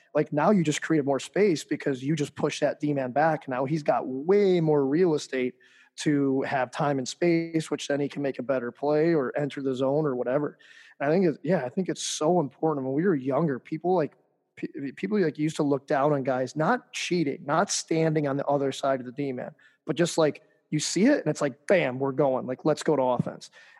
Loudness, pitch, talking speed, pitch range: -26 LUFS, 150 Hz, 230 wpm, 135-160 Hz